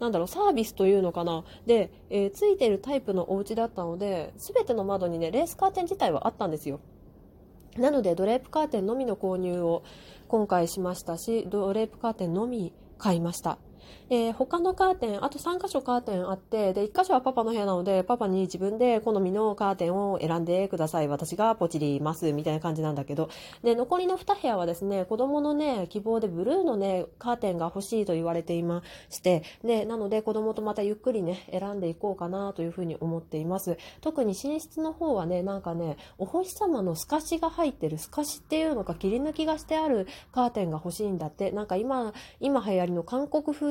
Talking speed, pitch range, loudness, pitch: 415 characters per minute, 175-250 Hz, -28 LUFS, 200 Hz